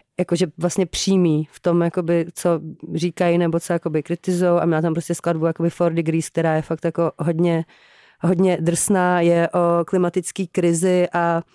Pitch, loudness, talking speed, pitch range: 170 Hz, -20 LUFS, 160 wpm, 165-175 Hz